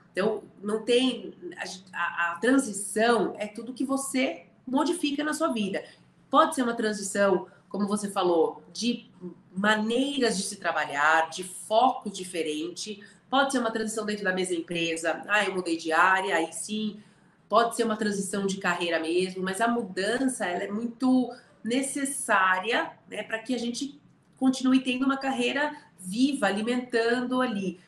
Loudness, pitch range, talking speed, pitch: -27 LUFS, 185-250 Hz, 155 wpm, 210 Hz